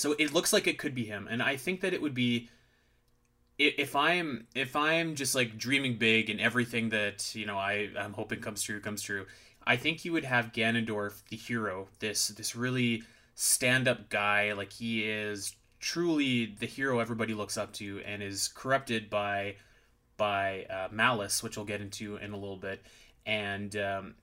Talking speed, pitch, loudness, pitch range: 190 wpm, 110 Hz, -31 LUFS, 105-125 Hz